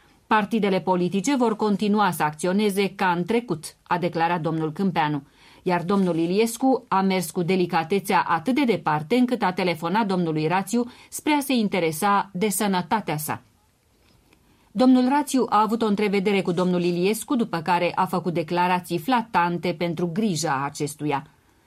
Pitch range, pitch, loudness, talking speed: 170-215 Hz, 185 Hz, -23 LUFS, 145 wpm